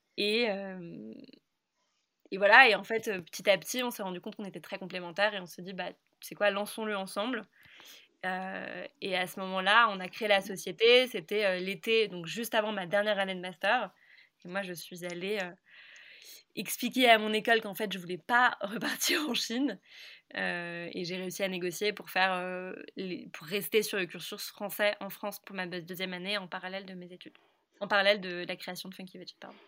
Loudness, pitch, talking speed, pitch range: -30 LUFS, 195 Hz, 200 wpm, 185-215 Hz